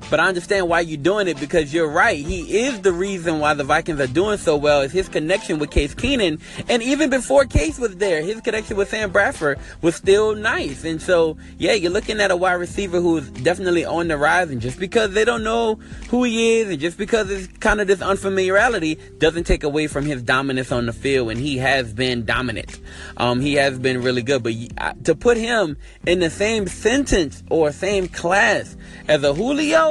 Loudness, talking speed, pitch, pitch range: -19 LUFS, 215 wpm, 175 Hz, 145-210 Hz